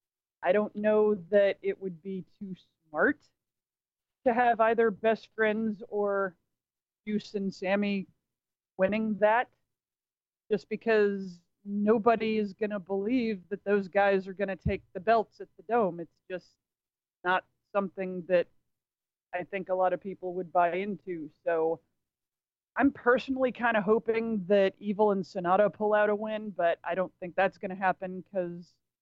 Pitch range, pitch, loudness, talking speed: 185-215 Hz, 200 Hz, -29 LUFS, 155 wpm